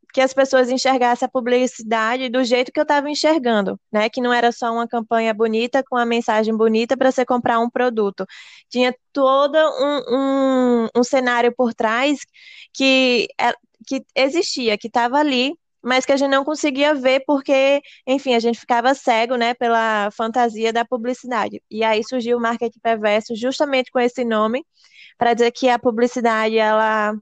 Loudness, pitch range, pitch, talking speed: -18 LUFS, 230-270 Hz, 250 Hz, 170 wpm